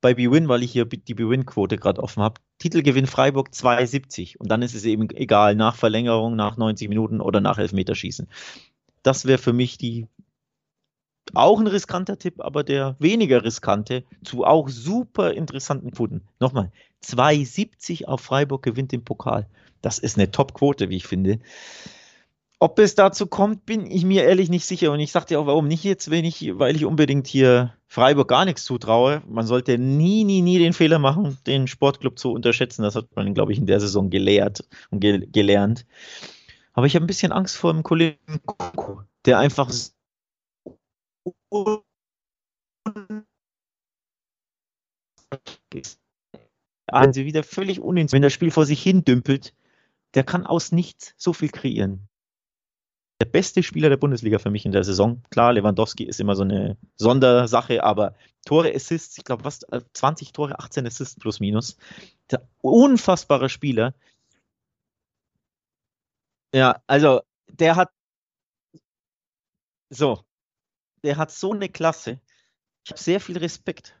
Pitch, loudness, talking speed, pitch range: 135 Hz, -21 LUFS, 145 wpm, 115-165 Hz